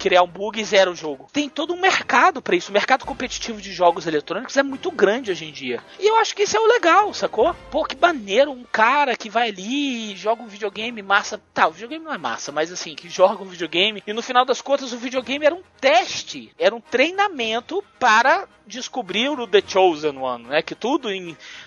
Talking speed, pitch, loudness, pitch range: 225 wpm, 230 Hz, -20 LUFS, 190-280 Hz